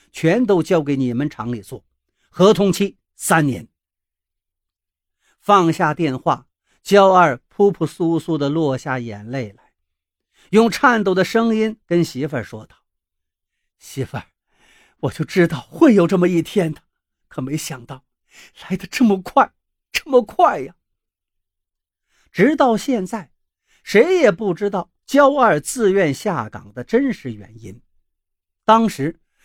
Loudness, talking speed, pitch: -17 LUFS, 185 characters per minute, 160 Hz